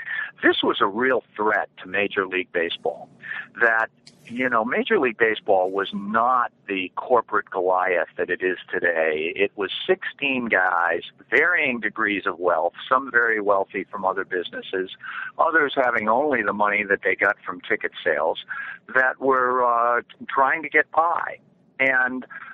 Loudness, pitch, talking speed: -22 LUFS, 130 Hz, 150 wpm